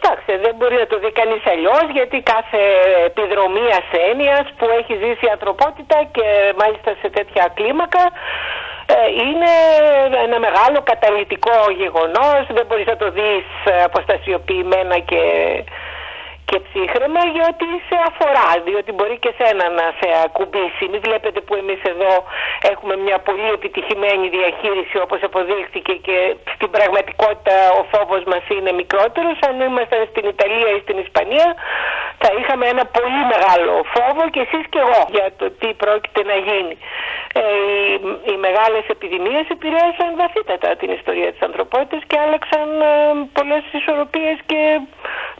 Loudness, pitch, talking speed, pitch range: -16 LUFS, 225 Hz, 140 wpm, 200-300 Hz